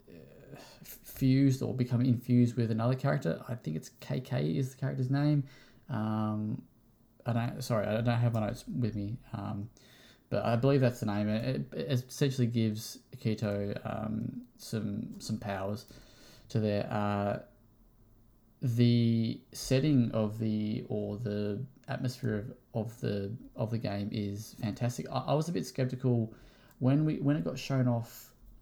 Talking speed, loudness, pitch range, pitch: 155 wpm, -32 LUFS, 110-125 Hz, 115 Hz